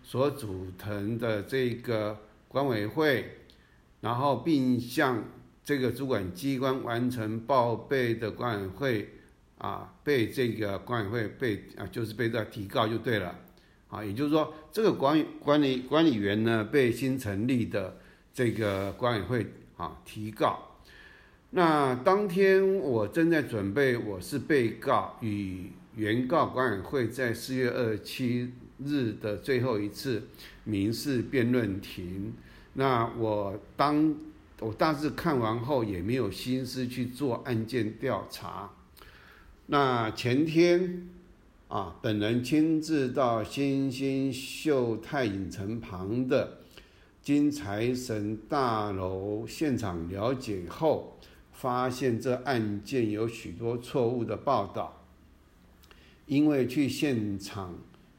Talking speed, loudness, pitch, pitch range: 180 characters per minute, -29 LUFS, 115 Hz, 100-135 Hz